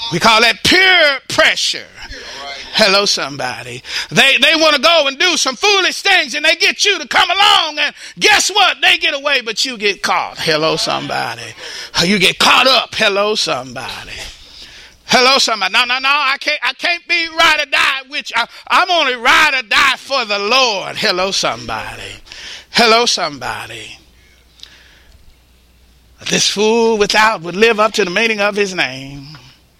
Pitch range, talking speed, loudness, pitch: 185-310 Hz, 160 wpm, -12 LUFS, 235 Hz